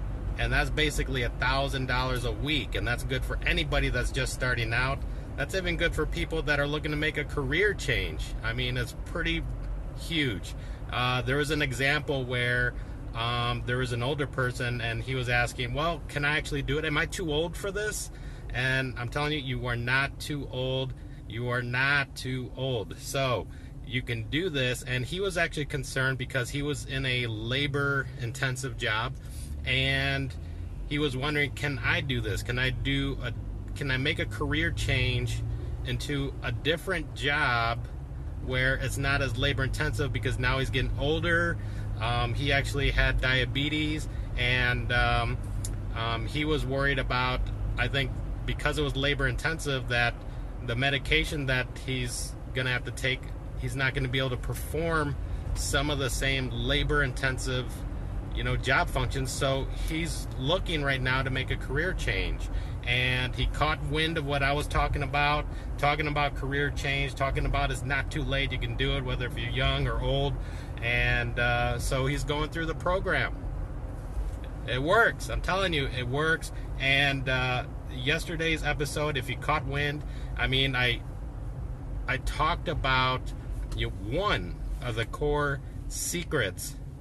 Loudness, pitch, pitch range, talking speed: -29 LUFS, 130 Hz, 120-140 Hz, 170 wpm